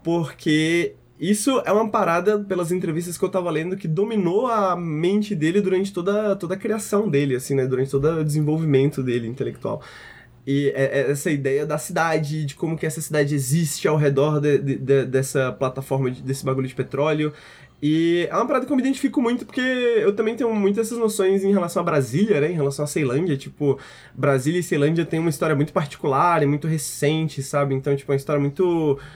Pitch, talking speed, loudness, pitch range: 155 Hz, 205 wpm, -22 LUFS, 140-190 Hz